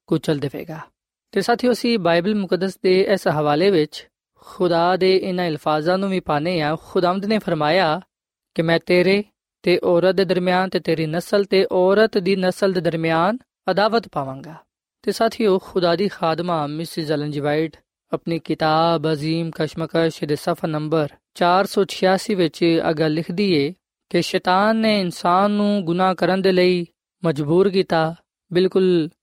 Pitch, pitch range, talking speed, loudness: 180 Hz, 165-190 Hz, 140 wpm, -20 LUFS